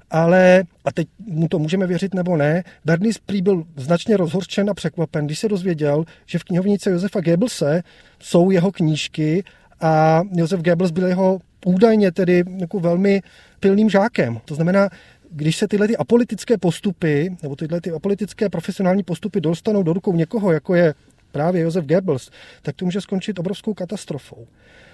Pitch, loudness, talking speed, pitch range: 180 Hz, -19 LUFS, 160 wpm, 165-200 Hz